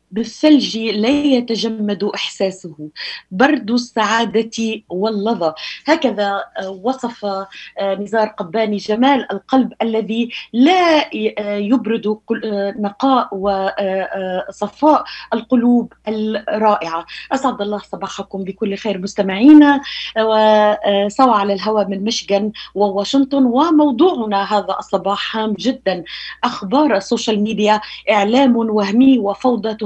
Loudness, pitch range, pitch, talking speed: -16 LUFS, 200-245 Hz, 215 Hz, 85 wpm